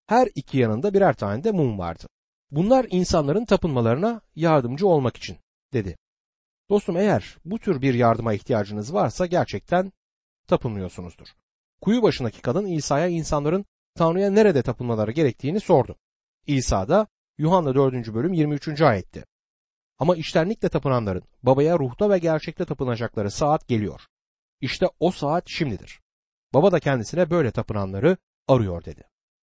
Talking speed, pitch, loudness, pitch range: 130 wpm, 155 Hz, -23 LUFS, 120-180 Hz